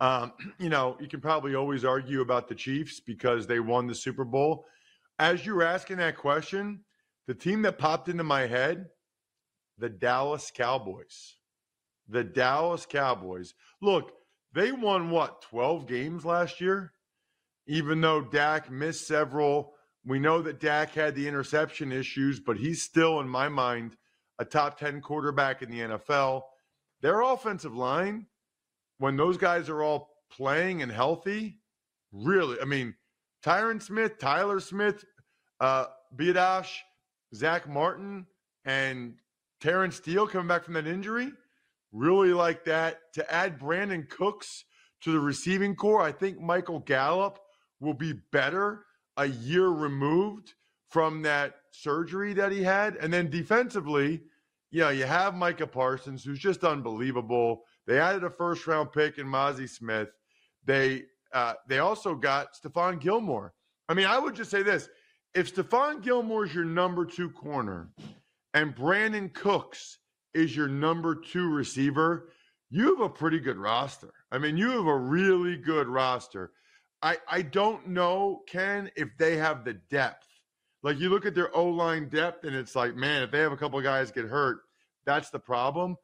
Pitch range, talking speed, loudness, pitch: 135-185 Hz, 155 wpm, -28 LUFS, 160 Hz